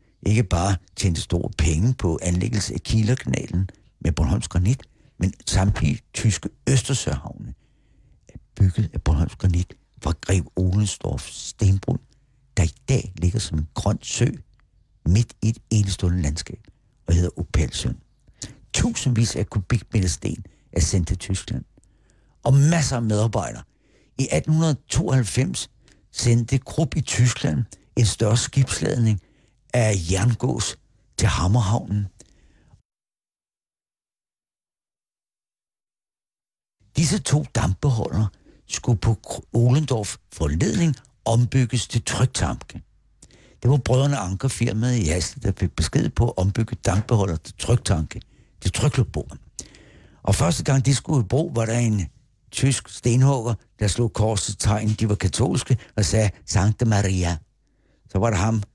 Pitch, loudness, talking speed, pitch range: 110 Hz, -23 LUFS, 120 wpm, 95-125 Hz